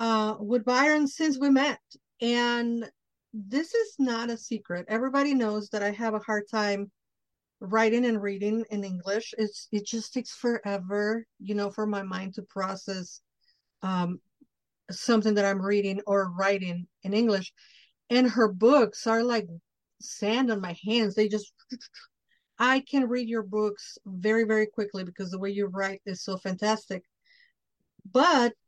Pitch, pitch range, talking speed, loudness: 215 Hz, 200-235 Hz, 155 wpm, -27 LUFS